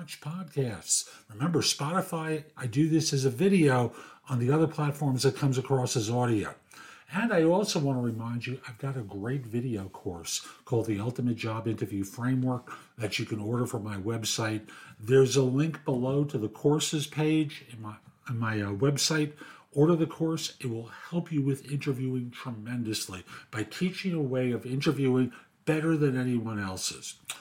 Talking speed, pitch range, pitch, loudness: 170 wpm, 115-150 Hz, 130 Hz, -29 LUFS